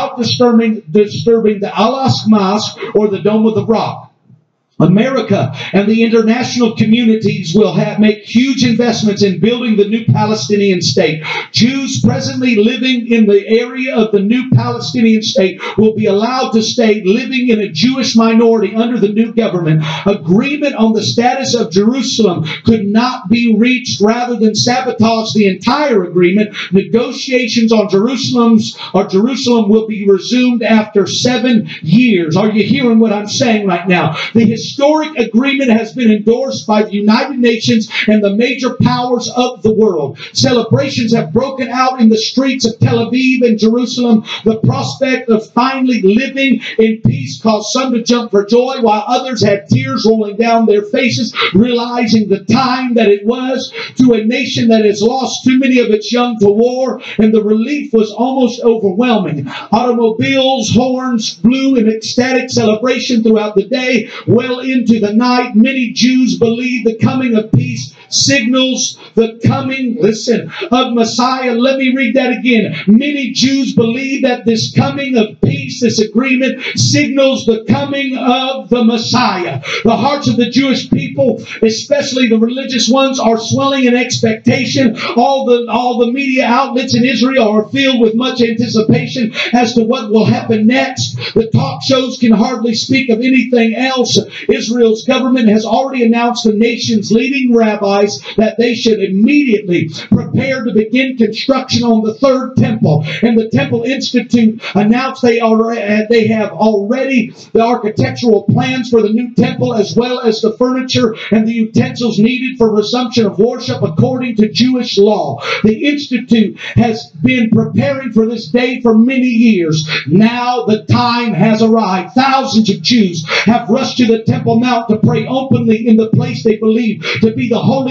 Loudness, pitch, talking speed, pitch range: -12 LUFS, 230 Hz, 160 wpm, 215-250 Hz